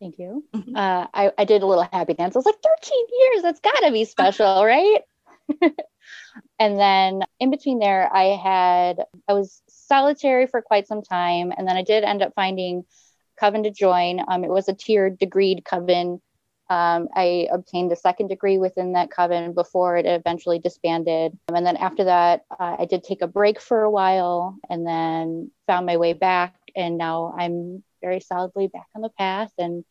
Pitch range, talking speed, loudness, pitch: 175-210 Hz, 190 wpm, -21 LUFS, 185 Hz